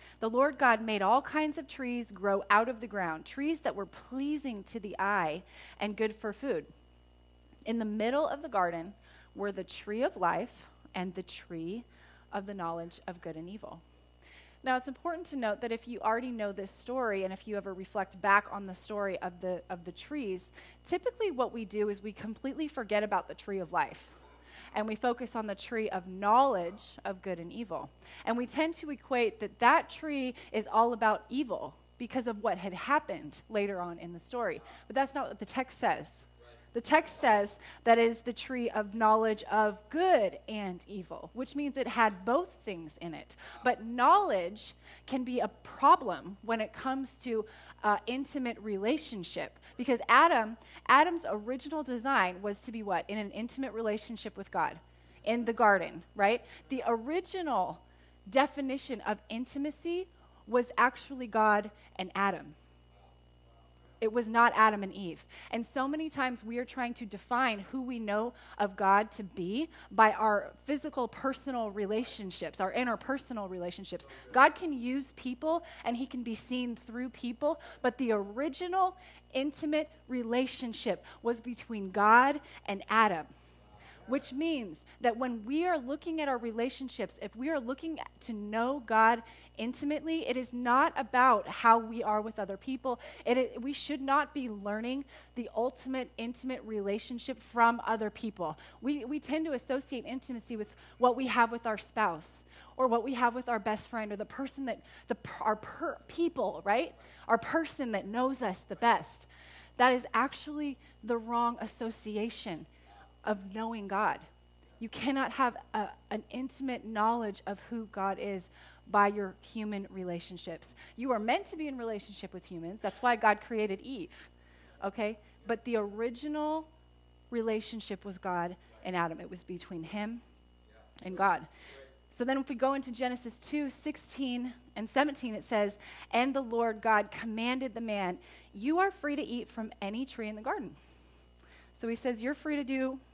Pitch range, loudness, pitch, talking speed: 200-260 Hz, -33 LUFS, 230 Hz, 170 wpm